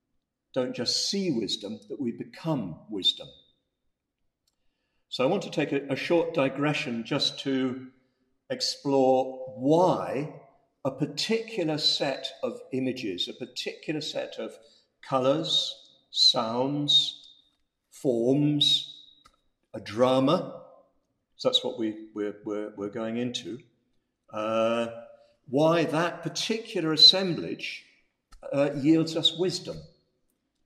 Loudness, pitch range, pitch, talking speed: -26 LUFS, 130-165 Hz, 140 Hz, 105 wpm